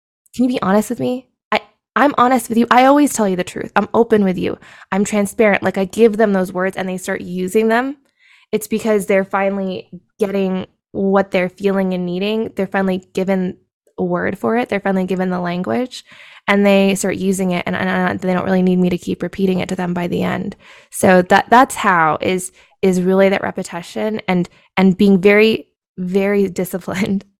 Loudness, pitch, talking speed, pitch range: -16 LUFS, 195 Hz, 205 wpm, 185-215 Hz